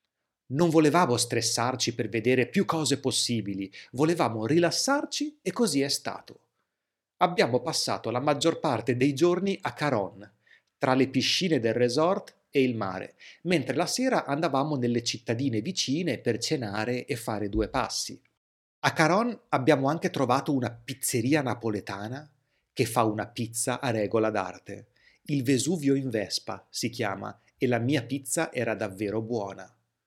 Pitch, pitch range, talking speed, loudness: 130 Hz, 115-155 Hz, 145 wpm, -27 LUFS